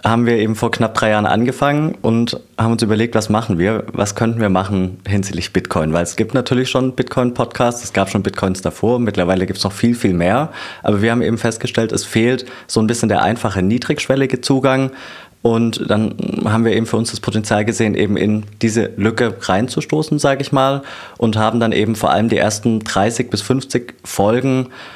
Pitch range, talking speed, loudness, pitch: 105-125 Hz, 200 wpm, -17 LUFS, 115 Hz